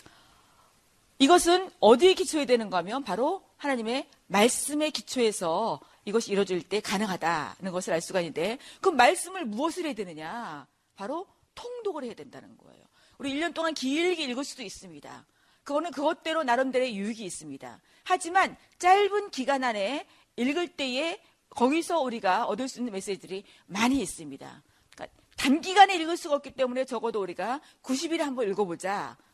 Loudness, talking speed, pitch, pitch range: -27 LUFS, 355 characters per minute, 265 Hz, 210-330 Hz